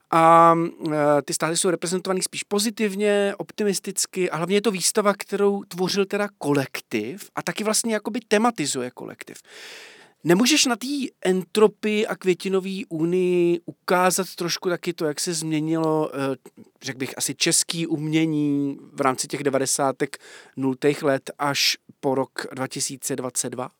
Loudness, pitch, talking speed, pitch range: -22 LUFS, 175 Hz, 130 wpm, 145-200 Hz